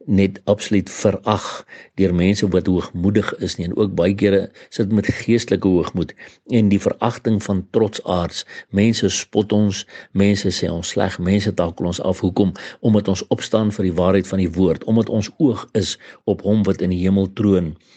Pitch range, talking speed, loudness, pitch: 90-105 Hz, 185 wpm, -19 LUFS, 100 Hz